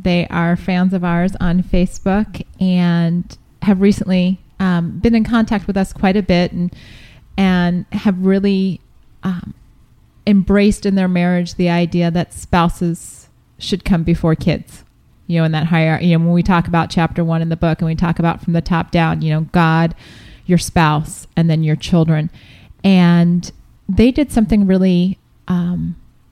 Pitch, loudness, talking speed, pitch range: 175 Hz, -16 LUFS, 170 wpm, 165-190 Hz